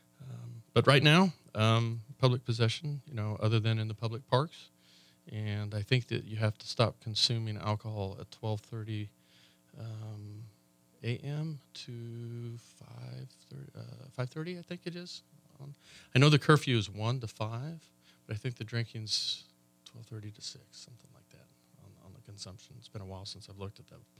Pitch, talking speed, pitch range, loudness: 115 Hz, 175 wpm, 105-130 Hz, -32 LUFS